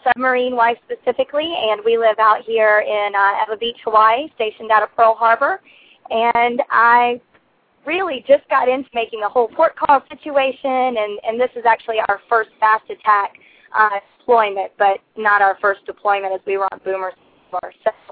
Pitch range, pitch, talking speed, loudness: 210-260 Hz, 230 Hz, 180 wpm, -17 LUFS